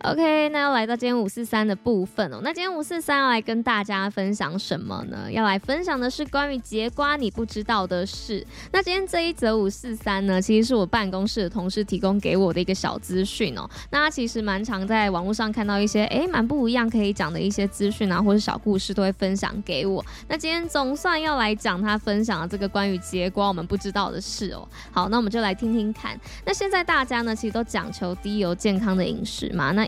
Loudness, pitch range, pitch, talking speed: -24 LUFS, 195-240 Hz, 215 Hz, 350 characters per minute